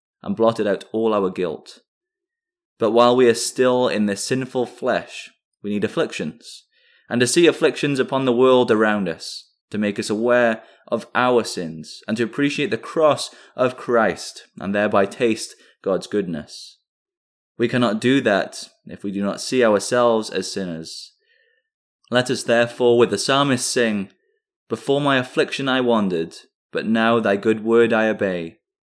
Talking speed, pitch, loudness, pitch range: 160 wpm, 120 Hz, -20 LUFS, 110-140 Hz